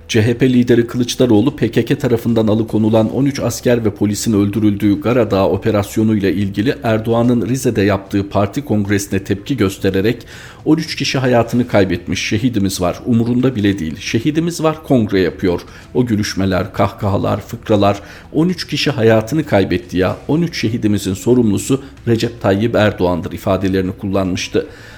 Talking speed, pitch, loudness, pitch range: 125 wpm, 110 Hz, -16 LUFS, 100-125 Hz